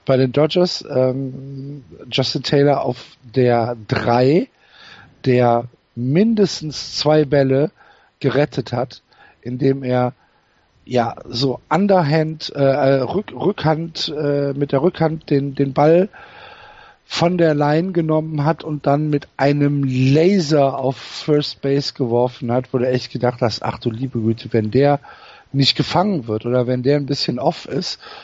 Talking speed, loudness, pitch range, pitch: 140 wpm, -18 LUFS, 125-155 Hz, 140 Hz